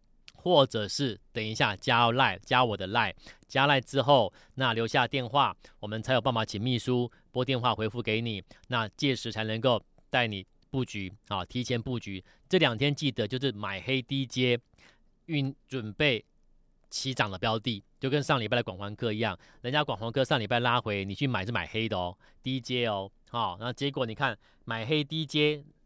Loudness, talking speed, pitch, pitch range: -29 LUFS, 265 characters per minute, 120 Hz, 110-135 Hz